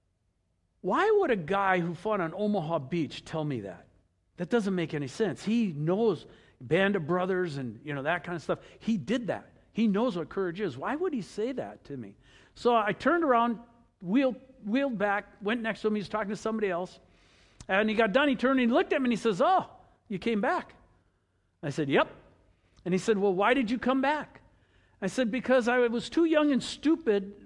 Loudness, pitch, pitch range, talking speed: -29 LUFS, 205 Hz, 155-240 Hz, 220 wpm